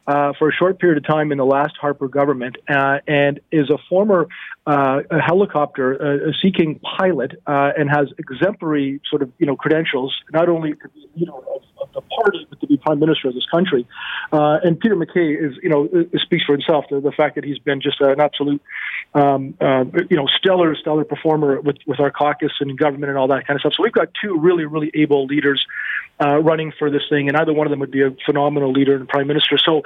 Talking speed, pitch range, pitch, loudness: 230 wpm, 140-160 Hz, 150 Hz, -18 LUFS